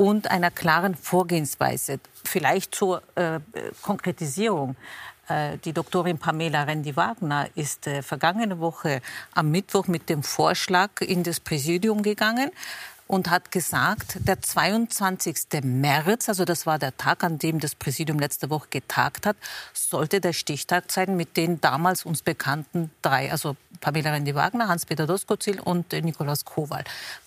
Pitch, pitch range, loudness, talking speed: 170 Hz, 155-185 Hz, -25 LUFS, 140 wpm